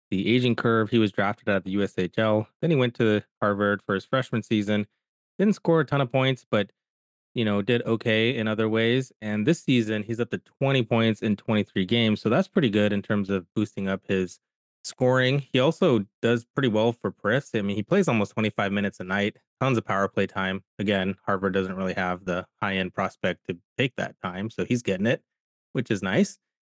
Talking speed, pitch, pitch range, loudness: 215 wpm, 110 Hz, 100-120 Hz, -25 LUFS